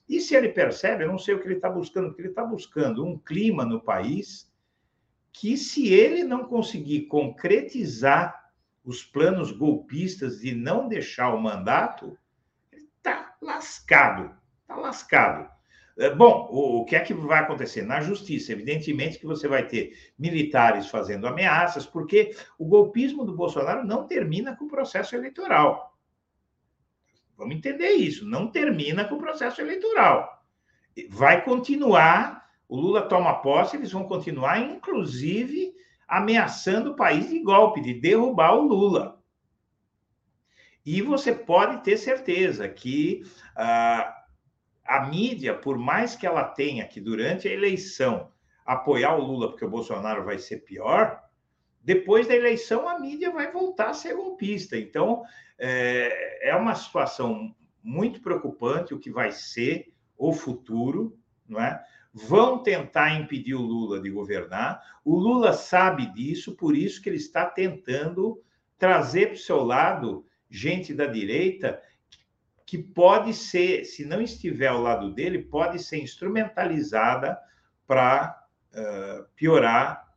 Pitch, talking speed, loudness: 195 Hz, 140 wpm, -24 LUFS